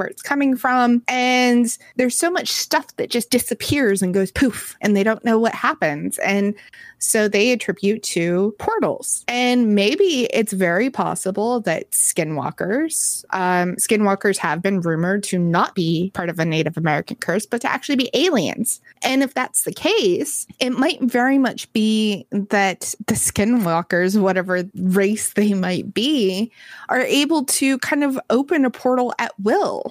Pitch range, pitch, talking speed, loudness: 190-250 Hz, 220 Hz, 165 wpm, -19 LUFS